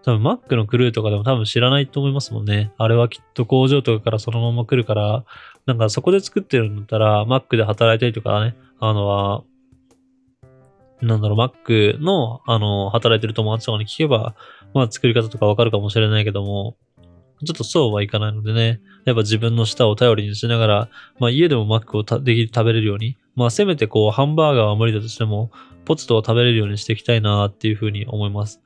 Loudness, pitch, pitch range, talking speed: -18 LUFS, 115 Hz, 105-125 Hz, 450 characters per minute